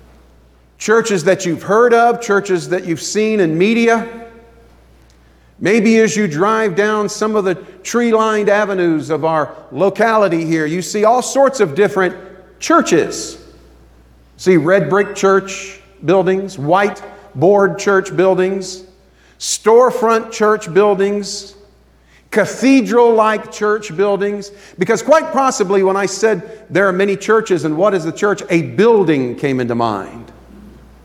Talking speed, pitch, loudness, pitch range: 135 wpm, 195 Hz, -14 LUFS, 170-215 Hz